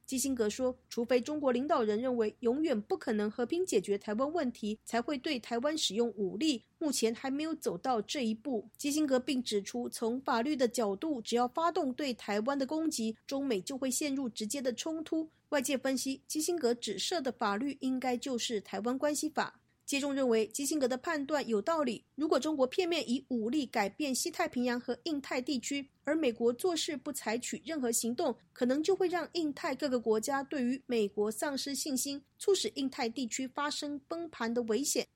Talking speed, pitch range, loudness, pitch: 300 characters per minute, 235-300 Hz, -34 LUFS, 265 Hz